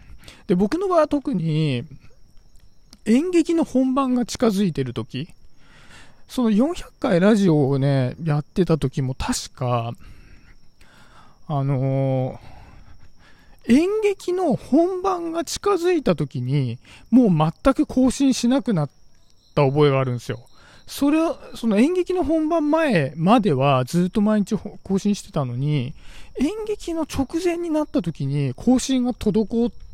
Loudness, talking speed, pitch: -21 LUFS, 230 characters per minute, 210 Hz